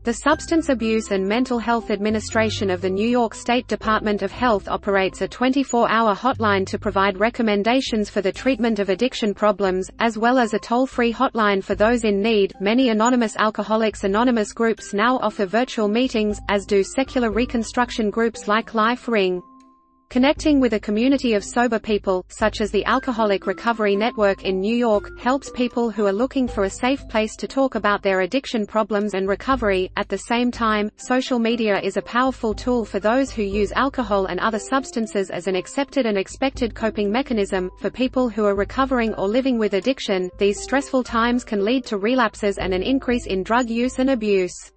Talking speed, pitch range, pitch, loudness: 185 wpm, 200-245 Hz, 220 Hz, -21 LUFS